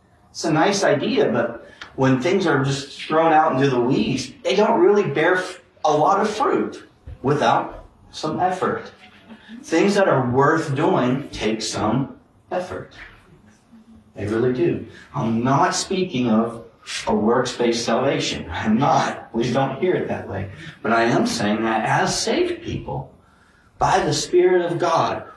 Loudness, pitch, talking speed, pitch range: -20 LUFS, 135 Hz, 150 wpm, 115-180 Hz